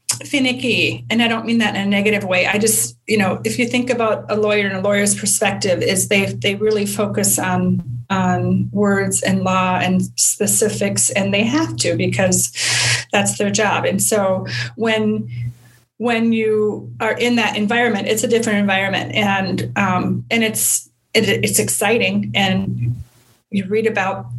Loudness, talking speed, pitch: -17 LUFS, 165 wpm, 200 Hz